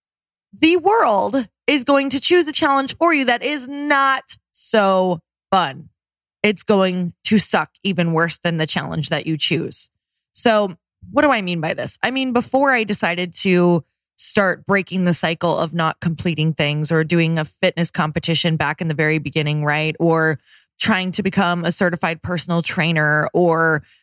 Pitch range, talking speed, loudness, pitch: 160-220 Hz, 170 wpm, -18 LUFS, 175 Hz